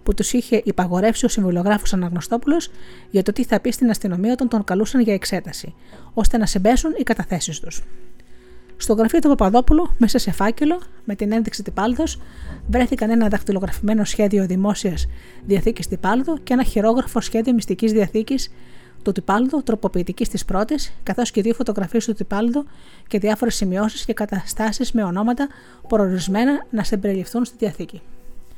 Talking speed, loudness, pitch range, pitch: 150 wpm, -20 LUFS, 195-240 Hz, 215 Hz